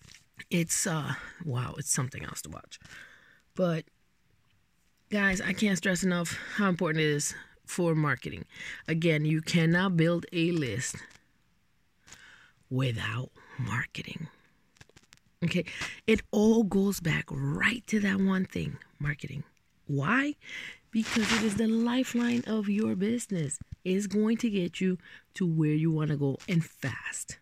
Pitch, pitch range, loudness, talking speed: 170 Hz, 150-205 Hz, -29 LUFS, 135 wpm